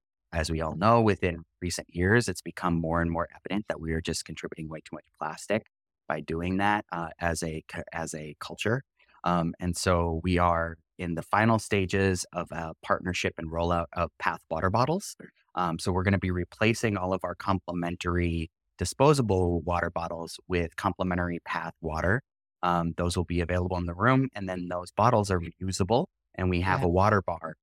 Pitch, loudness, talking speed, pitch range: 90 Hz, -28 LUFS, 190 wpm, 85-95 Hz